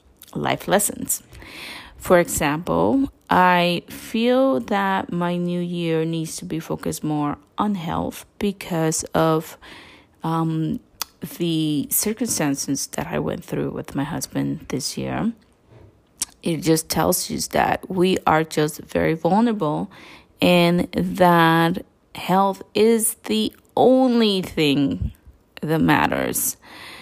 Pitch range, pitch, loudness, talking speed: 160-205 Hz, 175 Hz, -21 LUFS, 110 wpm